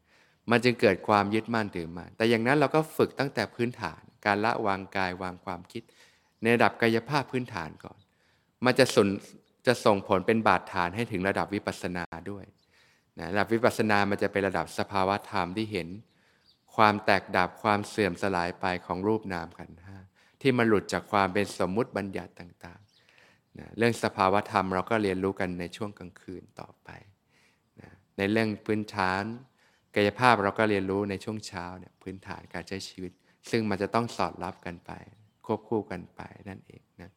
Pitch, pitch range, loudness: 100 Hz, 90-110 Hz, -28 LUFS